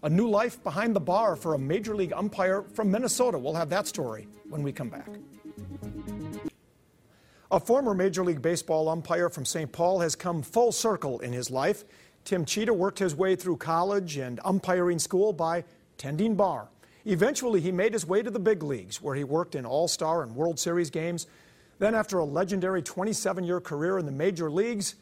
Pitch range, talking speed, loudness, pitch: 150-195 Hz, 190 wpm, -28 LUFS, 175 Hz